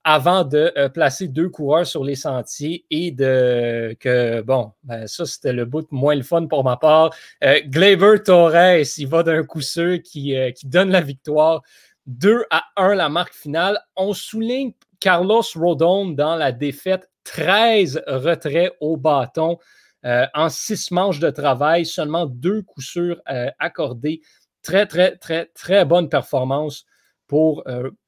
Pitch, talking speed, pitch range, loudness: 160 Hz, 160 wpm, 140-180 Hz, -18 LUFS